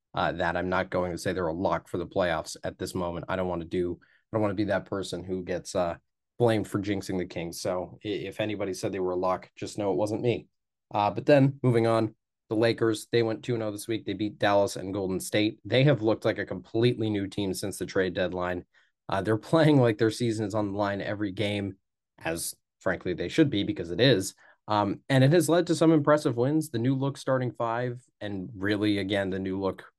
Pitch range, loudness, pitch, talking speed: 95-115 Hz, -28 LUFS, 105 Hz, 240 wpm